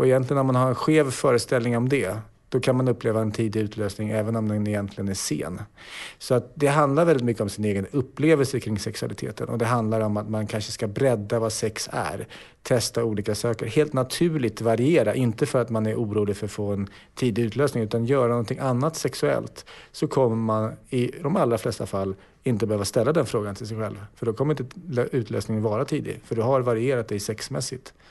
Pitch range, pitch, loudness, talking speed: 110-130 Hz, 115 Hz, -25 LUFS, 210 wpm